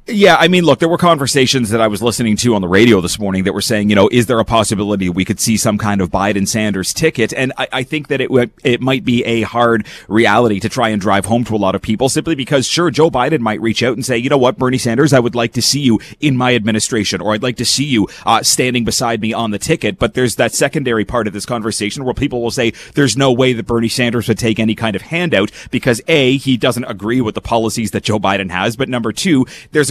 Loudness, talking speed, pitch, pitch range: -14 LUFS, 270 wpm, 120 Hz, 110-130 Hz